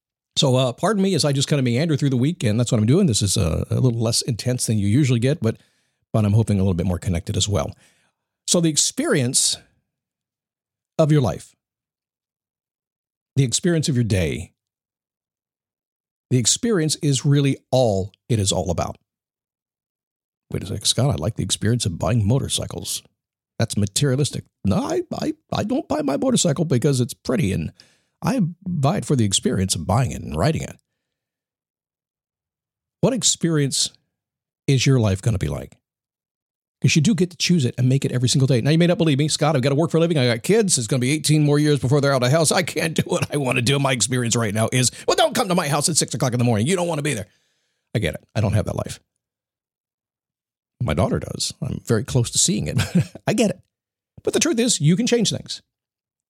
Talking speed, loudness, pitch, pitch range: 220 wpm, -20 LUFS, 135 Hz, 115-160 Hz